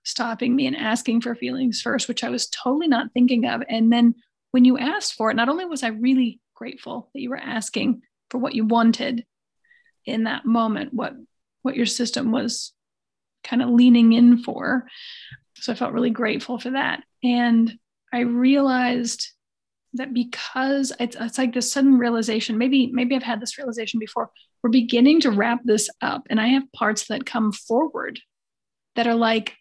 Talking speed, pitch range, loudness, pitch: 180 wpm, 230-260 Hz, -21 LUFS, 245 Hz